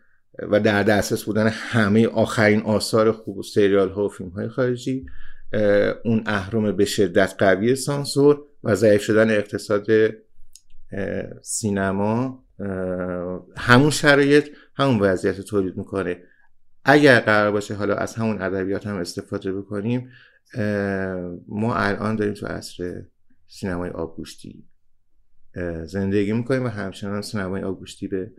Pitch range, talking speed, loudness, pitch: 95-110 Hz, 125 wpm, -21 LUFS, 105 Hz